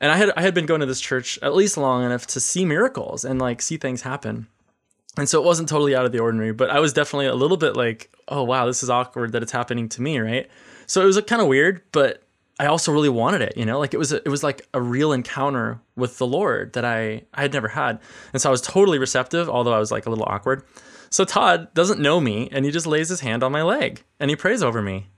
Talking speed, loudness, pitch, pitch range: 275 wpm, -21 LUFS, 130 Hz, 120-150 Hz